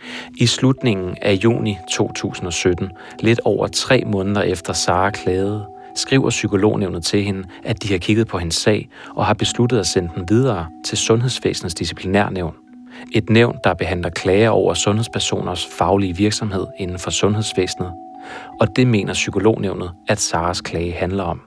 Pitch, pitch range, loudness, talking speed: 100 Hz, 90-115 Hz, -19 LUFS, 150 wpm